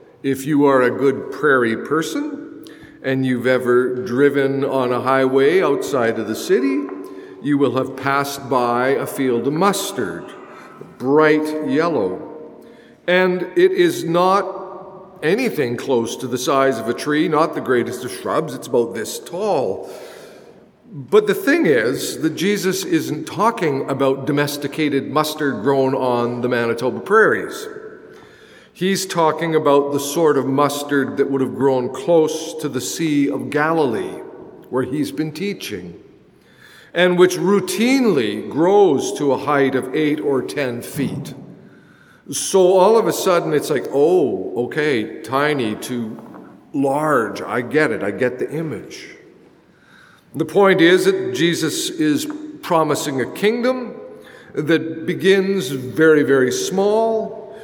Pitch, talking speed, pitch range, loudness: 155 Hz, 135 wpm, 135-200 Hz, -18 LUFS